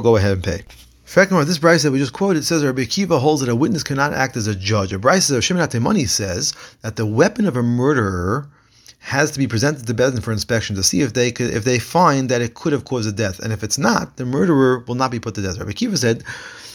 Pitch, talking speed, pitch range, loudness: 125 Hz, 260 wpm, 110-145 Hz, -18 LUFS